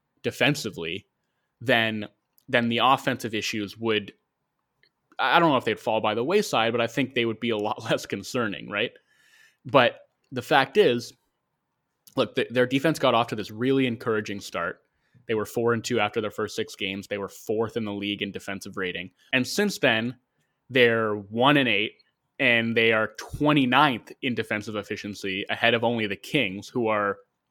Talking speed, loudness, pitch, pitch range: 180 wpm, -25 LUFS, 115 Hz, 105-125 Hz